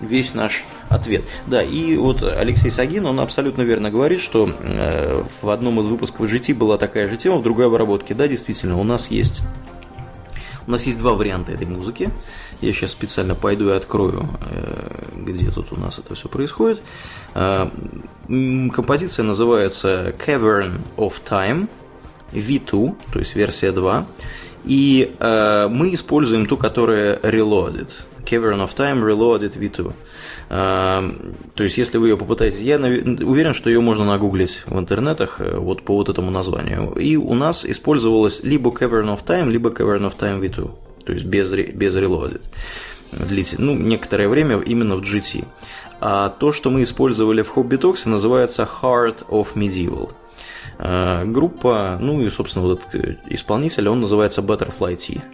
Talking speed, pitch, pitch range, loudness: 145 wpm, 110 Hz, 100-125 Hz, -19 LUFS